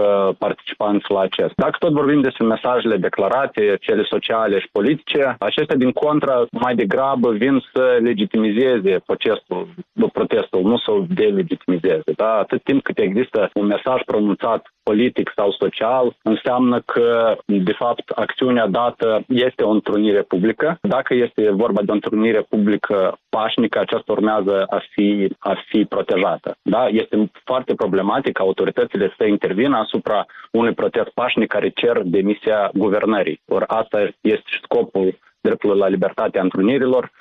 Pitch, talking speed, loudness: 125 Hz, 140 wpm, -18 LUFS